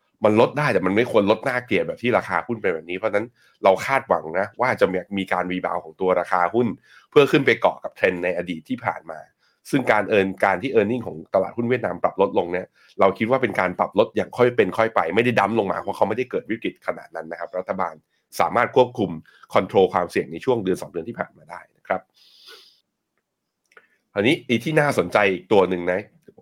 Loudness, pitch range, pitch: -22 LUFS, 90-120 Hz, 100 Hz